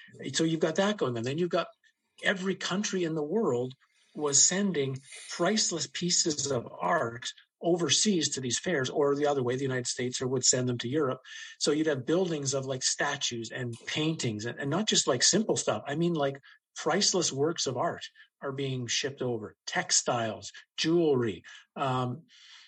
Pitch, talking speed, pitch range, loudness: 150 Hz, 175 wpm, 130-180 Hz, -29 LUFS